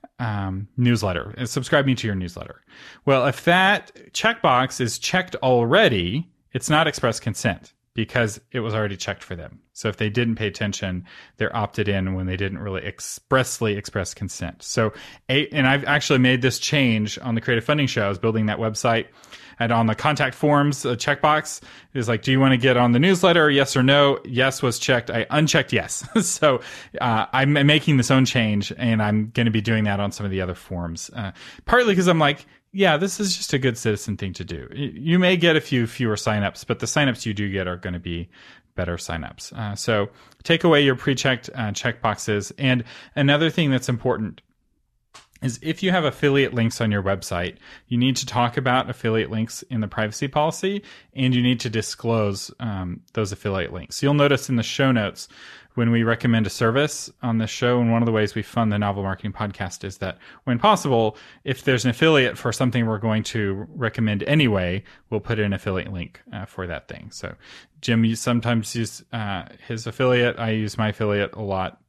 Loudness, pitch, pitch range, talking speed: -22 LUFS, 120 Hz, 105-135 Hz, 205 wpm